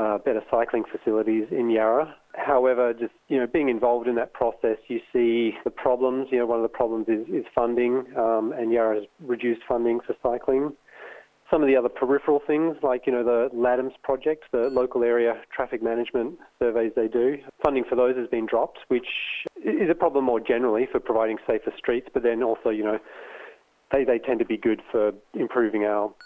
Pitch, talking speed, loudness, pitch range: 120 Hz, 195 wpm, -24 LUFS, 115-125 Hz